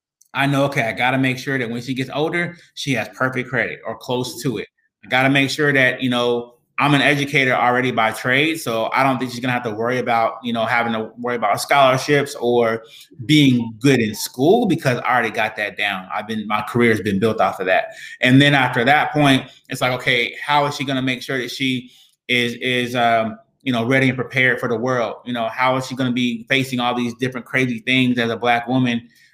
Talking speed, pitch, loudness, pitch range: 235 wpm, 125 Hz, -18 LUFS, 120-135 Hz